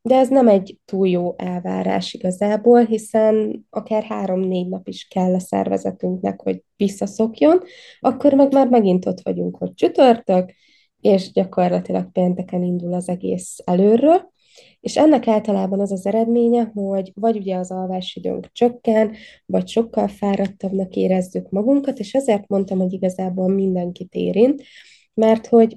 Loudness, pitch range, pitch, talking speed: -19 LUFS, 180-230 Hz, 195 Hz, 135 wpm